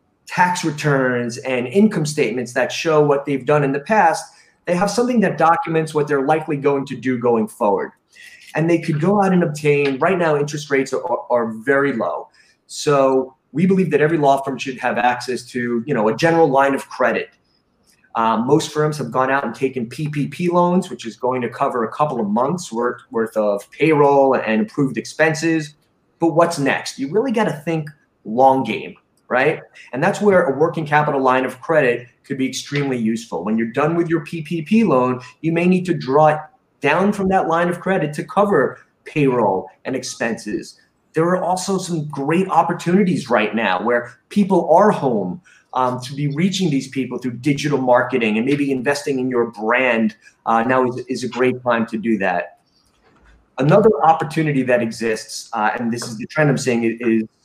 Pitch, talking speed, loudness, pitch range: 145 Hz, 190 wpm, -18 LUFS, 125-165 Hz